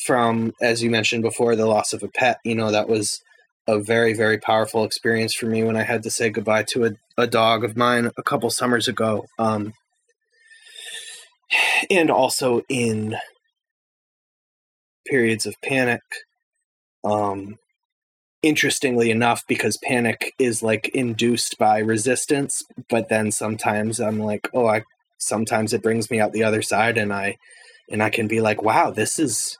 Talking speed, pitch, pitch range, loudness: 160 wpm, 115 Hz, 110-125 Hz, -21 LUFS